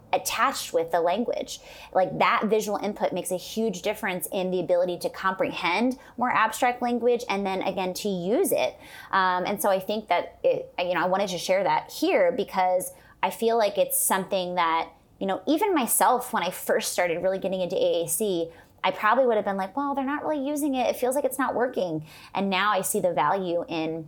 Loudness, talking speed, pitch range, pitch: -25 LUFS, 210 wpm, 180-245 Hz, 195 Hz